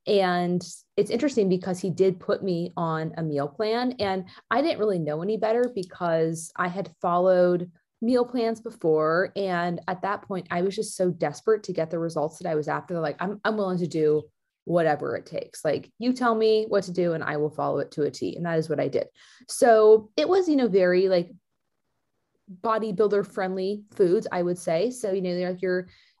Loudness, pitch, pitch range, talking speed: -25 LUFS, 185 Hz, 170-215 Hz, 210 wpm